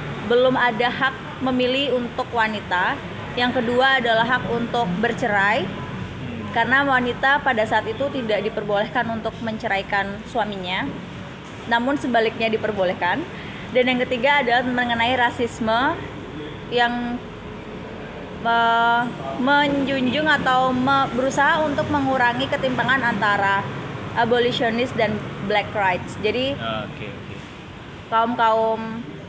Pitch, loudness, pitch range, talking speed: 240 Hz, -21 LUFS, 225-260 Hz, 100 wpm